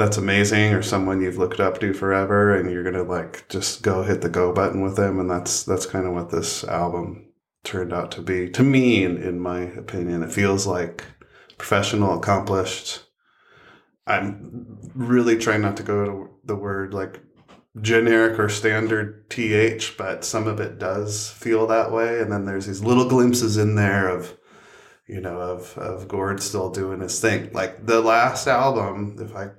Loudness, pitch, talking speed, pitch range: -22 LUFS, 100 Hz, 185 wpm, 95-110 Hz